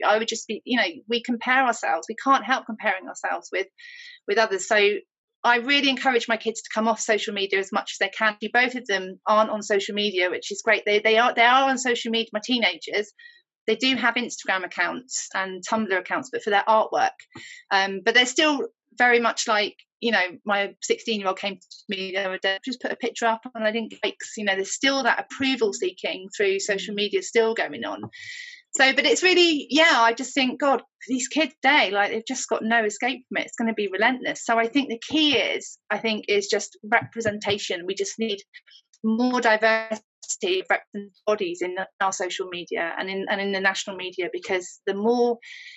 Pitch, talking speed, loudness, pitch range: 225 Hz, 210 wpm, -23 LUFS, 205-265 Hz